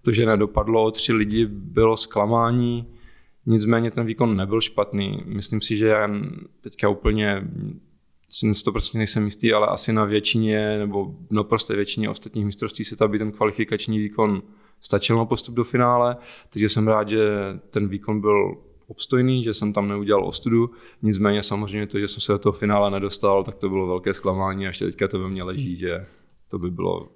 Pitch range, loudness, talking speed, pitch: 100-115 Hz, -22 LUFS, 180 wpm, 105 Hz